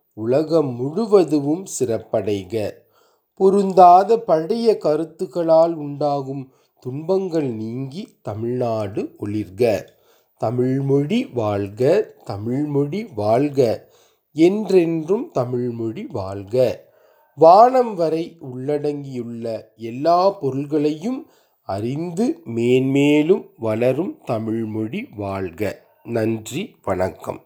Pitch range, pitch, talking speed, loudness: 115-180 Hz, 145 Hz, 65 wpm, -20 LUFS